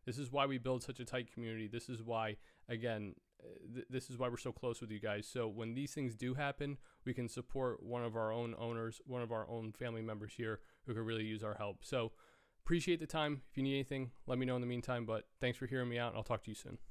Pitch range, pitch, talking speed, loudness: 115-130 Hz, 120 Hz, 270 wpm, -42 LUFS